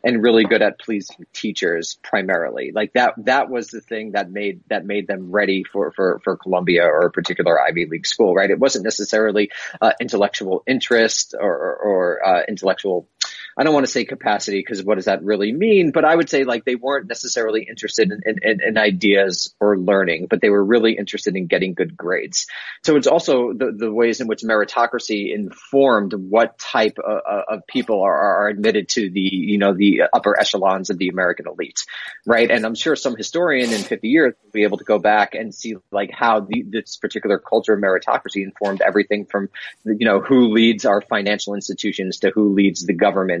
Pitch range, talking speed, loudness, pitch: 100-115 Hz, 200 wpm, -18 LUFS, 105 Hz